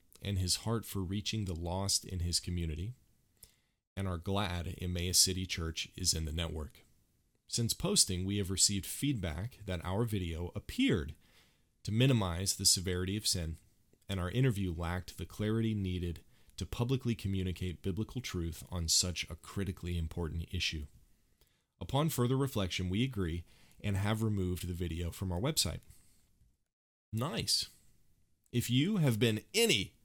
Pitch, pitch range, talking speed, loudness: 95 Hz, 85-110 Hz, 145 wpm, -34 LUFS